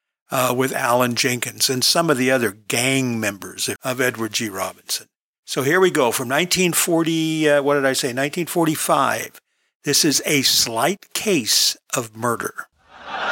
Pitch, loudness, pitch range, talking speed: 130 Hz, -19 LUFS, 120-160 Hz, 155 wpm